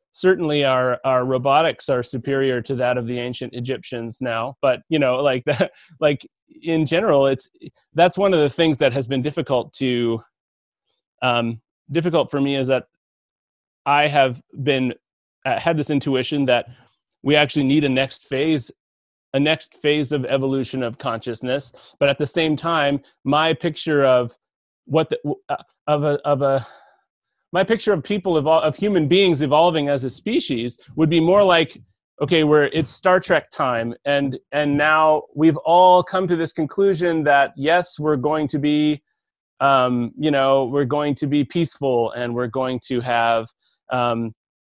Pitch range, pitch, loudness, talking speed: 130-160 Hz, 145 Hz, -20 LUFS, 170 wpm